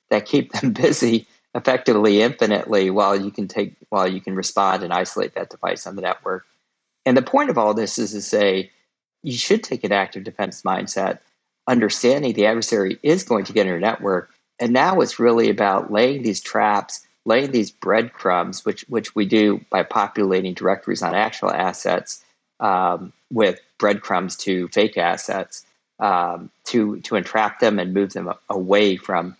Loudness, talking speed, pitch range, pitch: -20 LUFS, 170 wpm, 95-110 Hz, 100 Hz